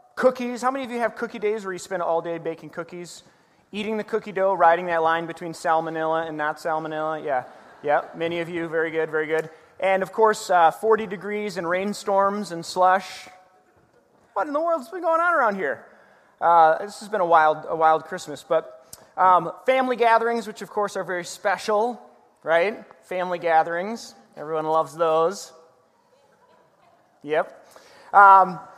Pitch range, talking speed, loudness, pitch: 165-210 Hz, 175 wpm, -22 LUFS, 180 Hz